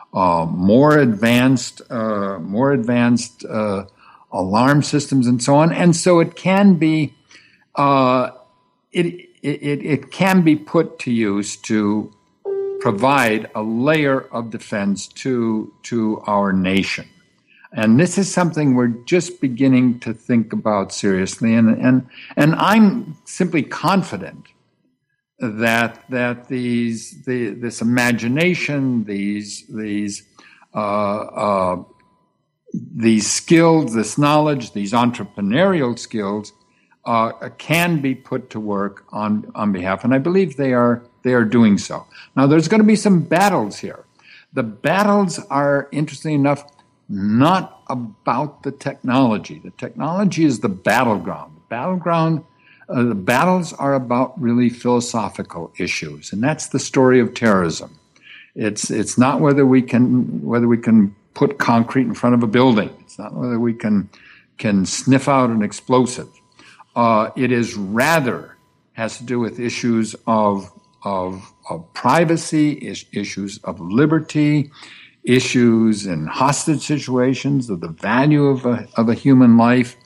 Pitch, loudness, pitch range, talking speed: 125 Hz, -18 LUFS, 110-145 Hz, 135 wpm